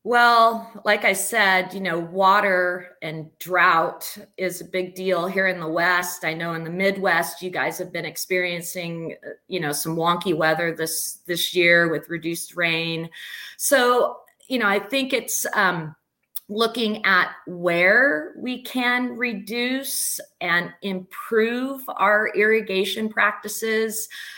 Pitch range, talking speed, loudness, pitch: 170-220 Hz, 140 wpm, -21 LUFS, 185 Hz